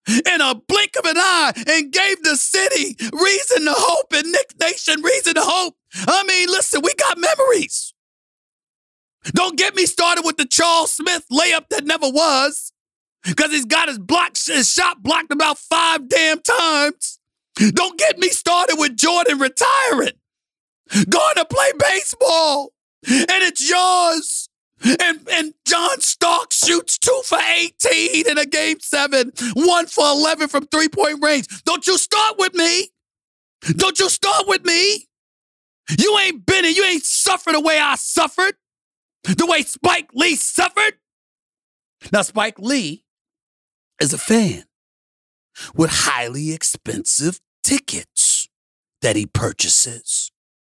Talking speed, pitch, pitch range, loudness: 140 wpm, 325 Hz, 285-360 Hz, -16 LUFS